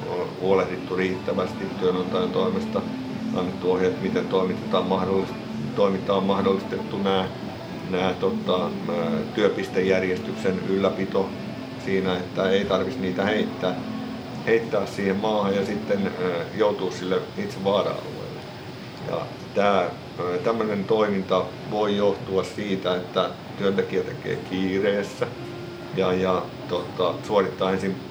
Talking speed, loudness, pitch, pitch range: 100 wpm, -25 LUFS, 95 Hz, 90-100 Hz